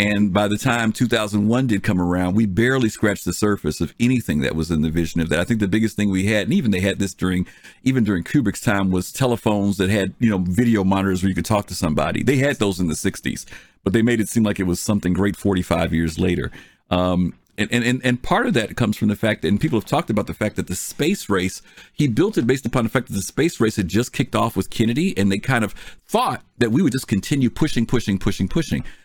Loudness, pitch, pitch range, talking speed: -20 LUFS, 105 Hz, 90-115 Hz, 260 wpm